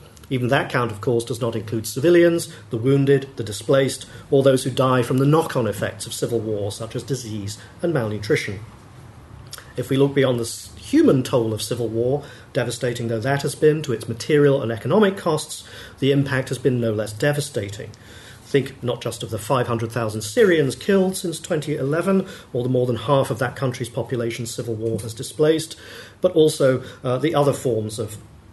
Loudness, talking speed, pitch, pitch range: -21 LUFS, 185 wpm, 125 Hz, 115-140 Hz